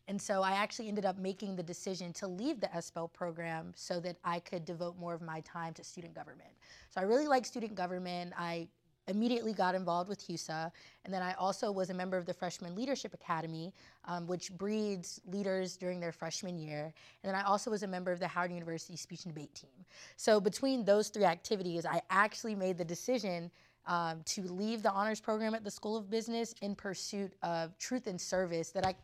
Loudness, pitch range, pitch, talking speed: -37 LUFS, 175-205 Hz, 185 Hz, 210 wpm